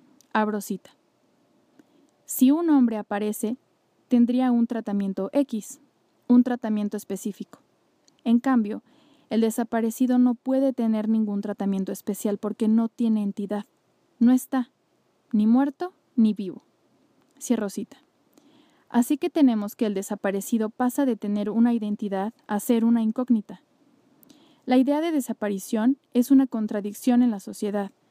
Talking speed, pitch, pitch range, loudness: 125 wpm, 240 Hz, 215-280 Hz, -24 LUFS